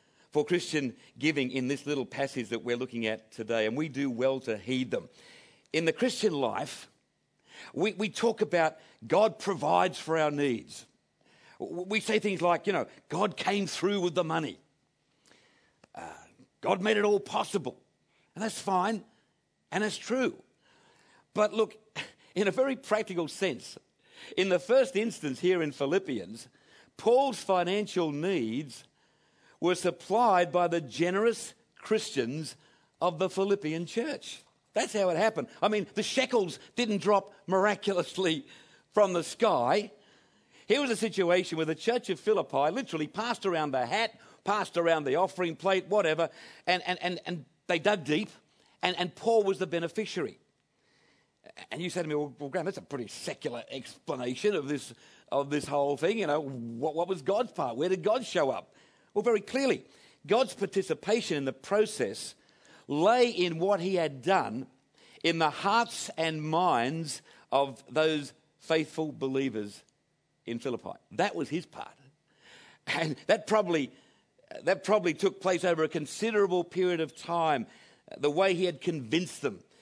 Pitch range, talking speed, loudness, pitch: 155-205 Hz, 155 wpm, -30 LUFS, 180 Hz